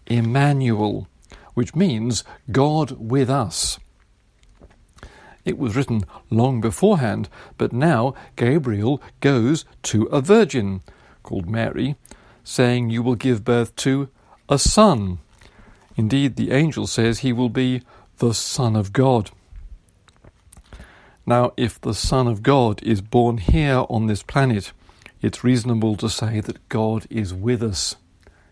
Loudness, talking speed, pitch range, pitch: -20 LUFS, 125 wpm, 100-130 Hz, 115 Hz